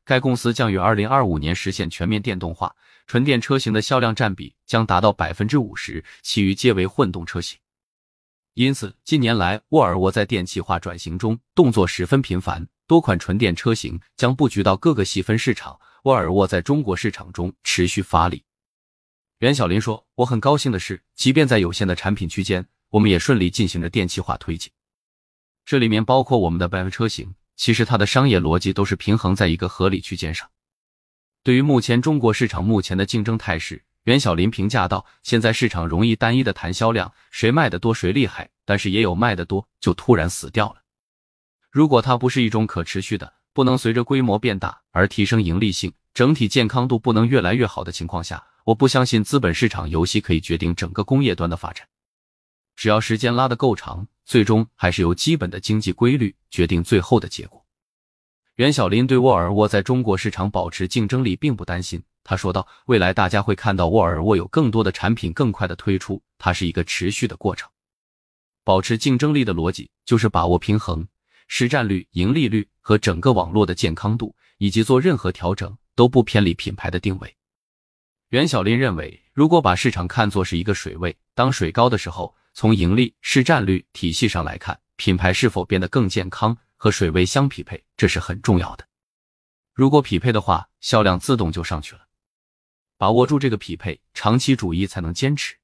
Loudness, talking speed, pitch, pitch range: -20 LUFS, 300 characters per minute, 105 Hz, 90-120 Hz